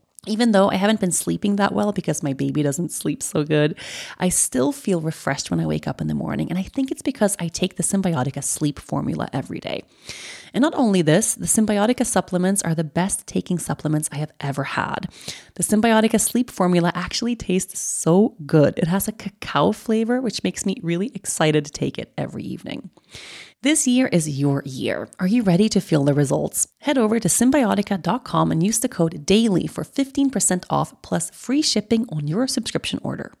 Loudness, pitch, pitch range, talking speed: -21 LUFS, 185 Hz, 155-220 Hz, 195 wpm